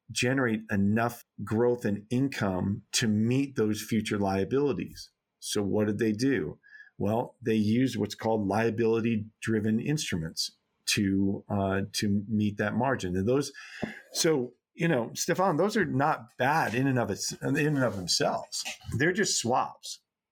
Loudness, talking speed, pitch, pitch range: -28 LUFS, 145 wpm, 110 Hz, 105-120 Hz